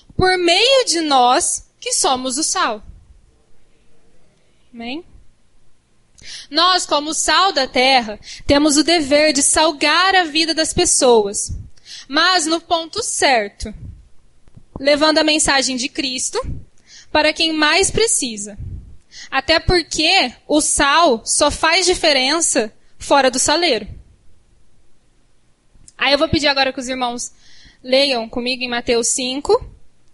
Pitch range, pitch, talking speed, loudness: 265-340 Hz, 305 Hz, 115 wpm, -15 LUFS